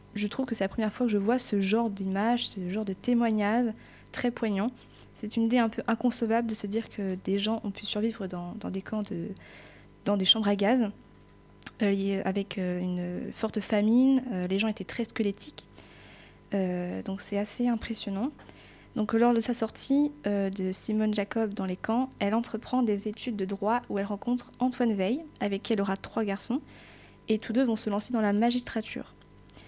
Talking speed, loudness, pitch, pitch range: 195 wpm, -29 LUFS, 215 Hz, 195-235 Hz